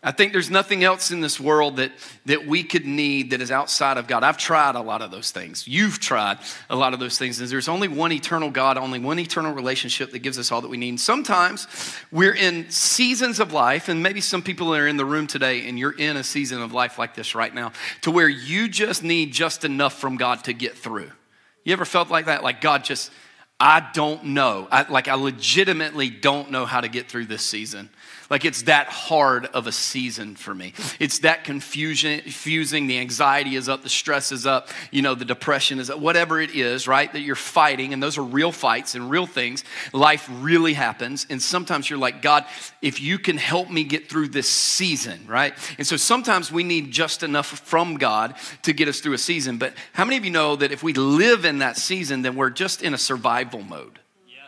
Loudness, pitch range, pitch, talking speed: -21 LUFS, 130-165 Hz, 145 Hz, 225 wpm